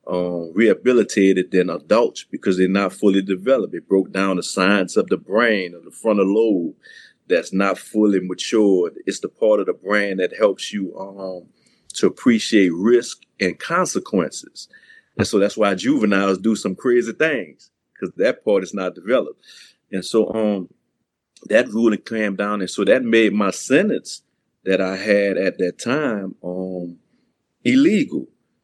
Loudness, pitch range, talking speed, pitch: -19 LUFS, 95-110 Hz, 160 wpm, 100 Hz